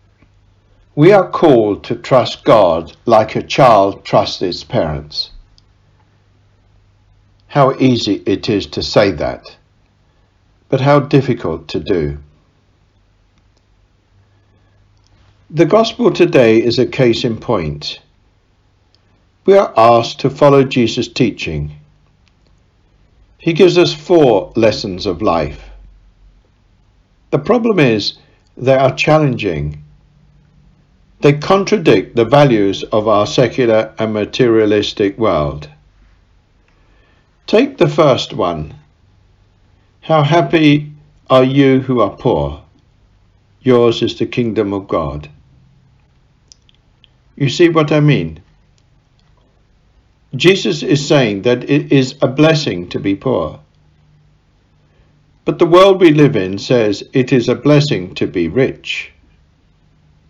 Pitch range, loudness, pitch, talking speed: 95-140 Hz, -13 LUFS, 105 Hz, 110 wpm